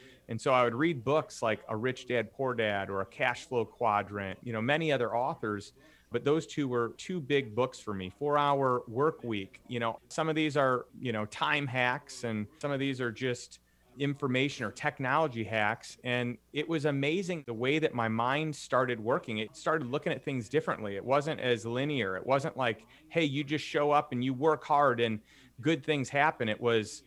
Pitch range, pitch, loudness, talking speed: 115-145 Hz, 130 Hz, -31 LUFS, 210 wpm